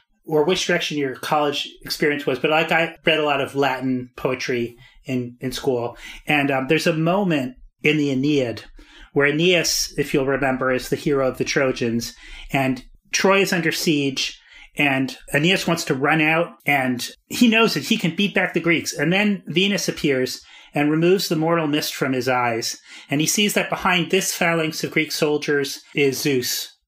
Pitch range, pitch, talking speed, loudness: 135-170 Hz, 150 Hz, 185 wpm, -20 LUFS